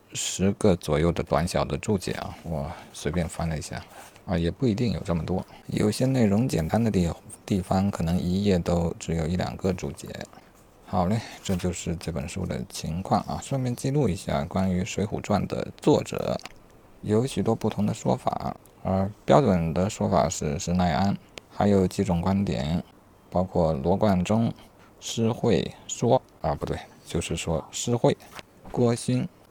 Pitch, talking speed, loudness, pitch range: 95 Hz, 240 characters per minute, -26 LUFS, 85-105 Hz